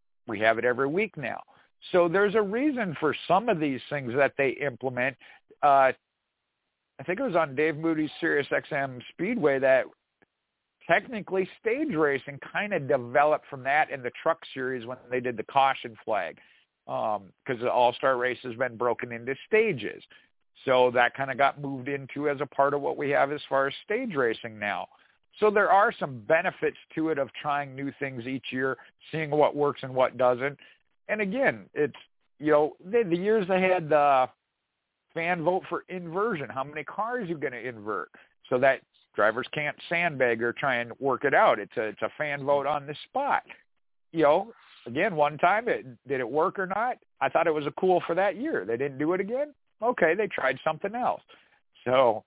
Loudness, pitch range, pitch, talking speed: -27 LUFS, 130-180 Hz, 145 Hz, 195 wpm